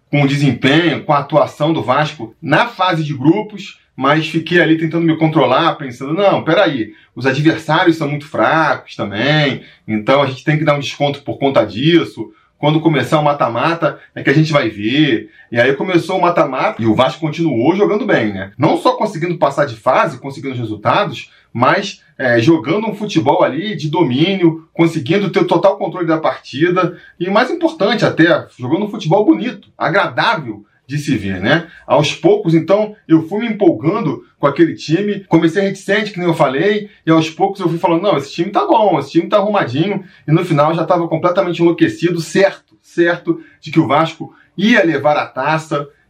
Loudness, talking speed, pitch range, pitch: -15 LUFS, 190 wpm, 145-180 Hz, 160 Hz